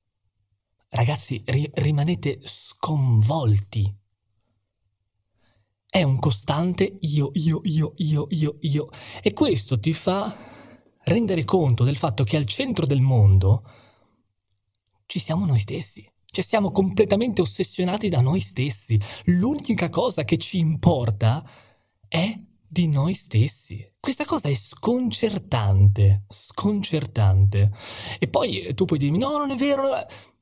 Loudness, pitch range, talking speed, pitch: -23 LUFS, 110-180 Hz, 120 wpm, 140 Hz